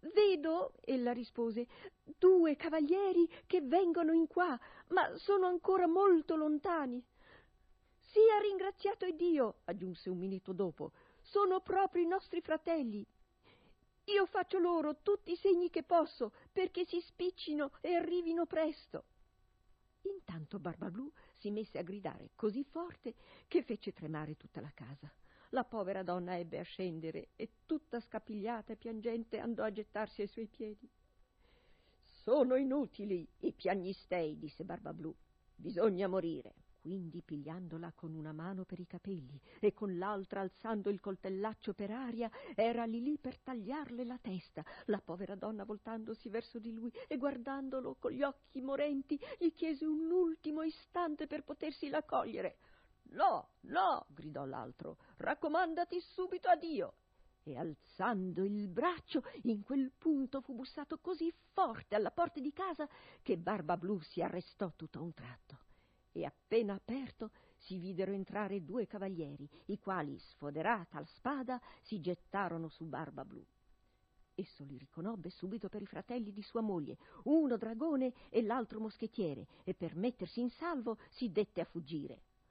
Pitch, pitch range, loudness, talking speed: 230 Hz, 190-315 Hz, -38 LUFS, 145 wpm